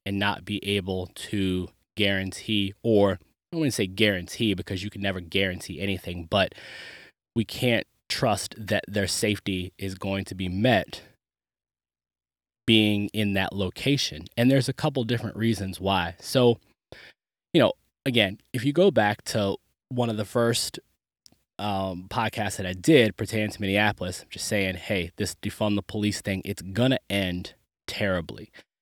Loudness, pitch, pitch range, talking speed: -26 LUFS, 100 Hz, 95-110 Hz, 150 wpm